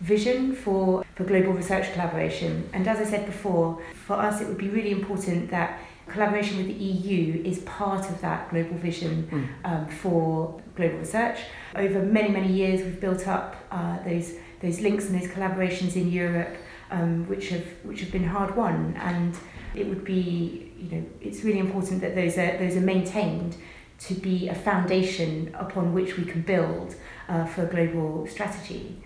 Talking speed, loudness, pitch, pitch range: 180 wpm, -27 LUFS, 185 Hz, 170-195 Hz